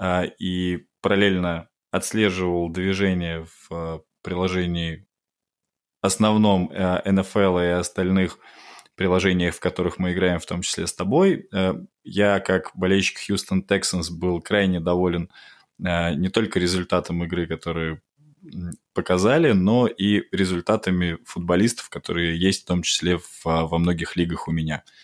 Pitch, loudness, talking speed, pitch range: 90 Hz, -22 LUFS, 115 wpm, 85-95 Hz